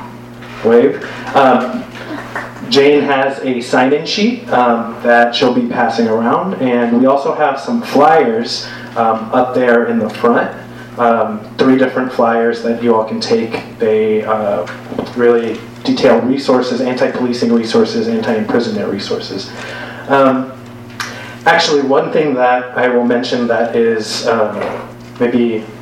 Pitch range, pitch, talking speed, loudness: 115-130 Hz, 120 Hz, 135 wpm, -13 LUFS